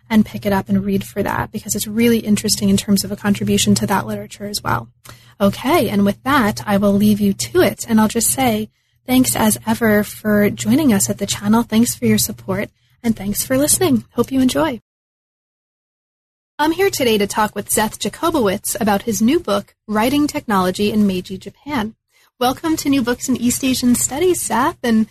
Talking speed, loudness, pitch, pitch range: 200 wpm, -17 LUFS, 215 Hz, 200-250 Hz